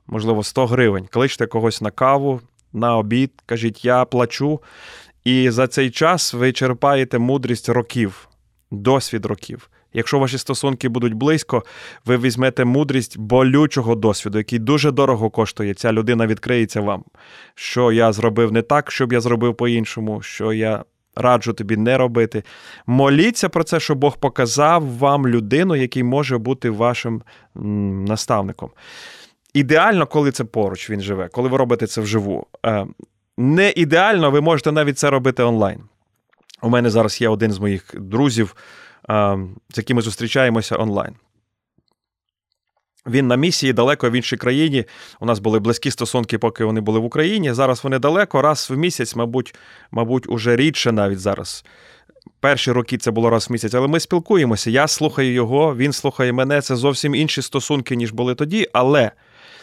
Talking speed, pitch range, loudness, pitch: 155 wpm, 110-140 Hz, -18 LUFS, 125 Hz